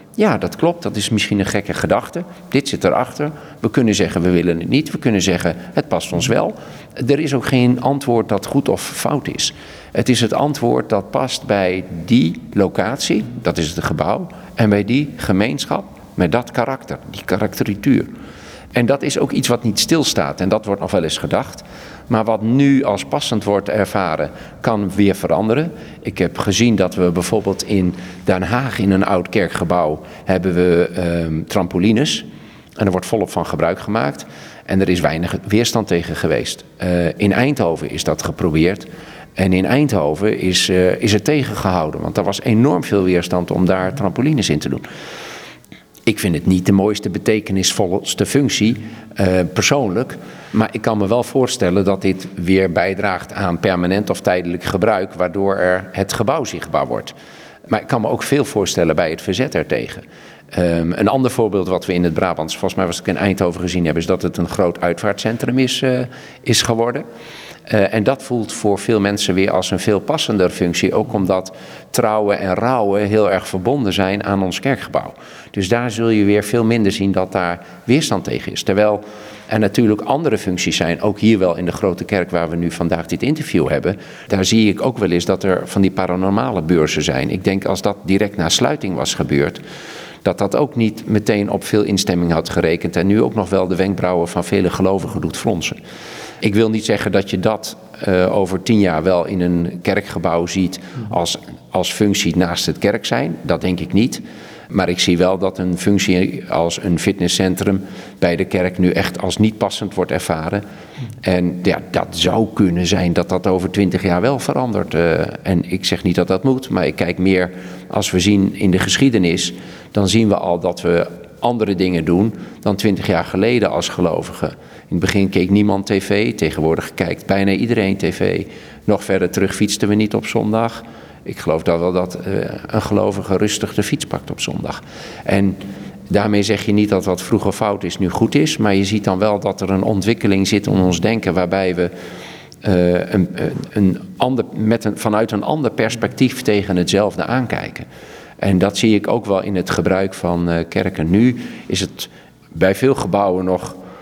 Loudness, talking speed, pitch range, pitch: -17 LUFS, 195 wpm, 90-110 Hz, 100 Hz